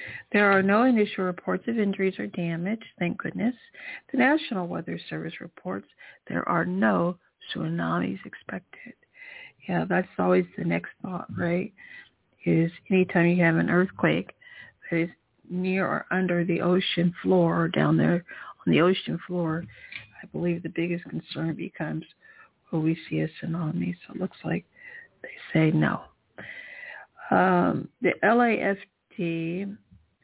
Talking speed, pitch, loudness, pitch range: 140 wpm, 180 Hz, -26 LUFS, 165-200 Hz